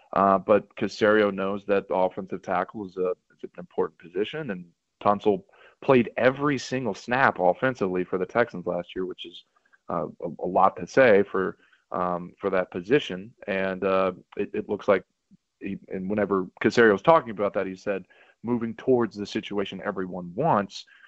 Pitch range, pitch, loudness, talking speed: 90-105 Hz, 95 Hz, -25 LUFS, 175 wpm